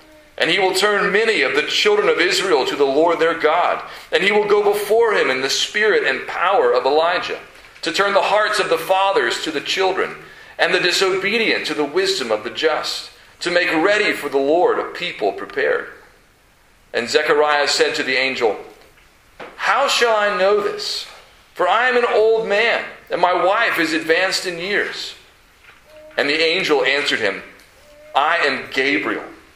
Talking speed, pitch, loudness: 180 wpm, 210 Hz, -17 LUFS